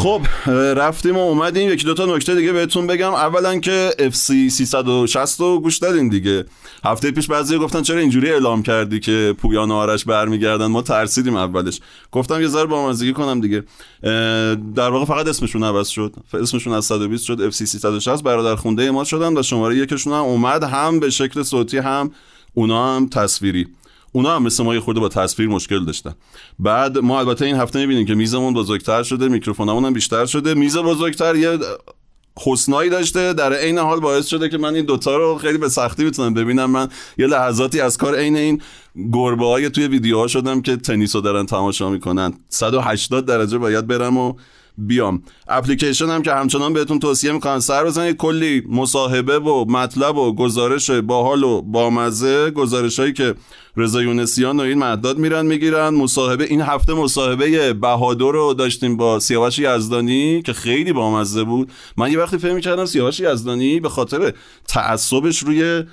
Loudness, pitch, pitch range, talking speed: -17 LUFS, 130 Hz, 115-150 Hz, 175 wpm